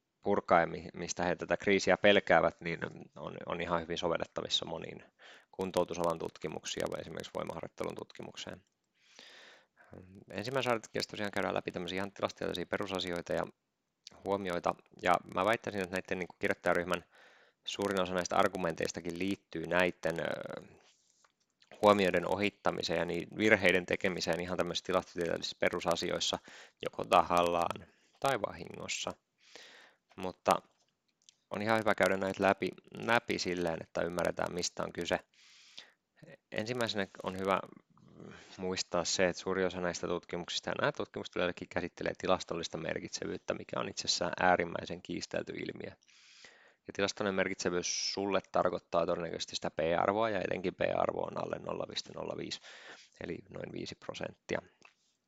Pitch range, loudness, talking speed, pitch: 85-100 Hz, -34 LUFS, 120 wpm, 95 Hz